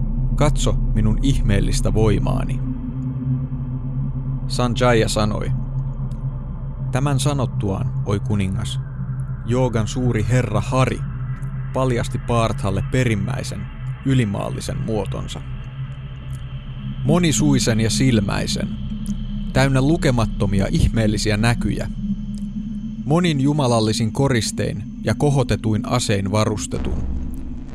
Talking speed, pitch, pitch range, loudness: 70 wpm, 125 Hz, 110-130 Hz, -21 LUFS